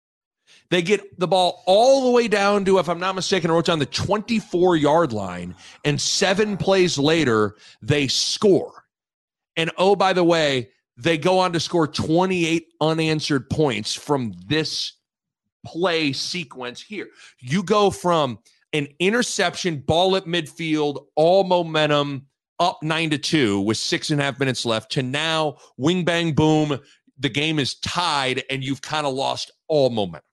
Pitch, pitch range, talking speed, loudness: 160 Hz, 140-180 Hz, 160 wpm, -21 LUFS